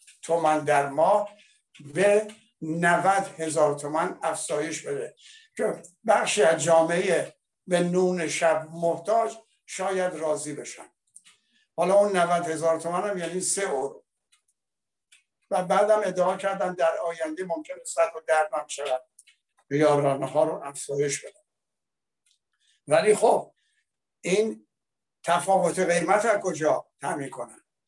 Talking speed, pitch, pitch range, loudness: 115 wpm, 175 Hz, 160-200 Hz, -25 LUFS